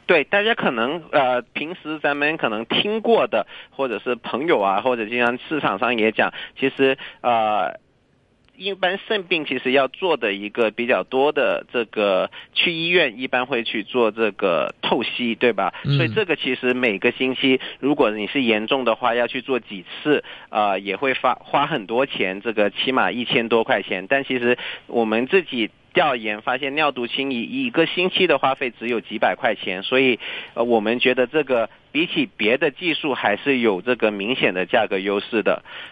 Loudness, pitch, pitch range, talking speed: -21 LUFS, 125 Hz, 115-140 Hz, 265 characters per minute